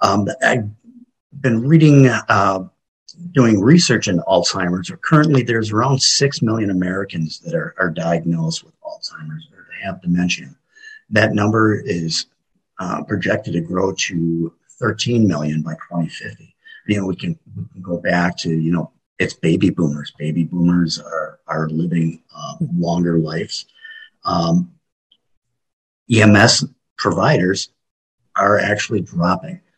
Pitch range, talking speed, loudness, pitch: 85-140 Hz, 125 wpm, -17 LUFS, 100 Hz